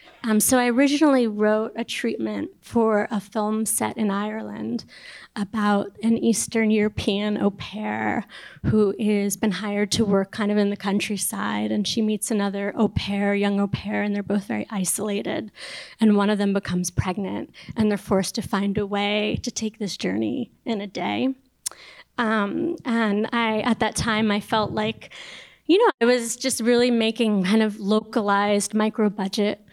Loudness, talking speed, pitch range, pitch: -23 LUFS, 170 wpm, 200-225 Hz, 210 Hz